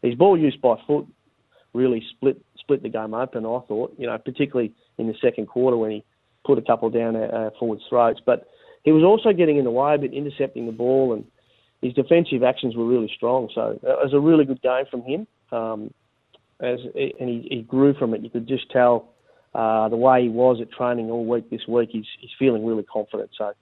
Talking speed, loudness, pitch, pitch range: 225 wpm, -22 LUFS, 125 Hz, 115-135 Hz